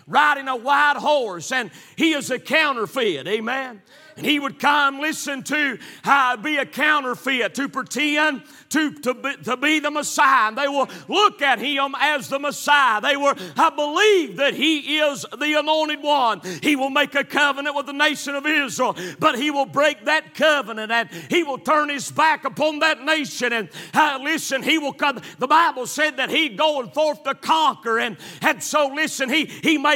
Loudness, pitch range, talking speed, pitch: -20 LUFS, 265-305 Hz, 190 wpm, 285 Hz